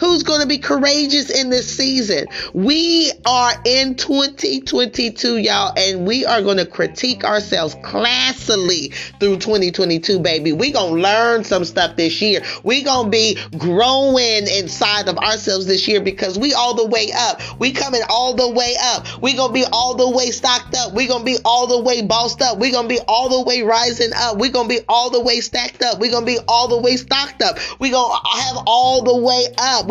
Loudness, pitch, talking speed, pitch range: -16 LUFS, 240 Hz, 195 wpm, 215-255 Hz